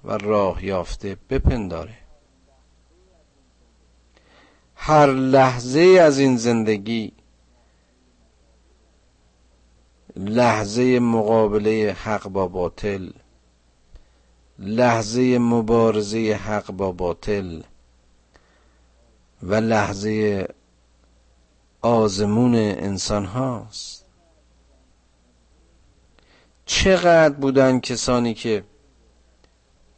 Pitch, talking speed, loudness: 95 Hz, 55 wpm, -19 LUFS